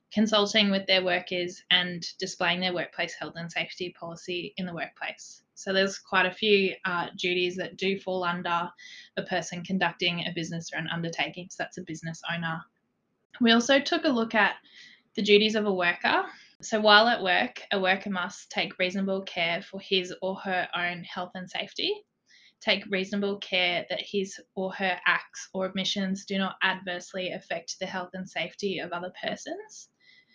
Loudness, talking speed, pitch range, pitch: -27 LUFS, 175 wpm, 175-200 Hz, 185 Hz